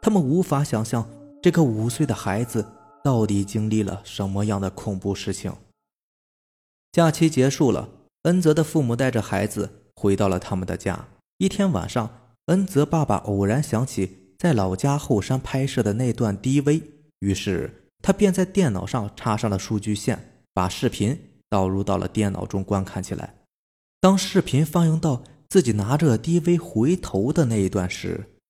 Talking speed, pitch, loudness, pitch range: 250 characters per minute, 115 Hz, -23 LUFS, 100-150 Hz